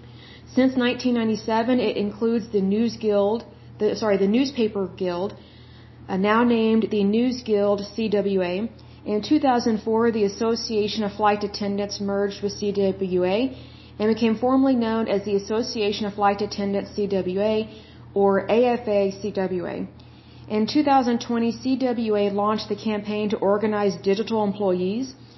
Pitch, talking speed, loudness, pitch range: 210 Hz, 125 wpm, -23 LUFS, 200-230 Hz